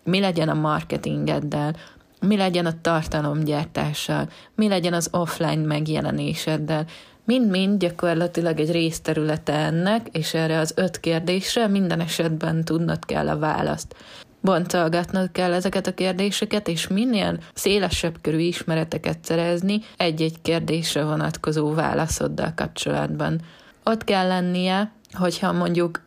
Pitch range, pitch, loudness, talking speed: 155-185 Hz, 165 Hz, -23 LUFS, 115 wpm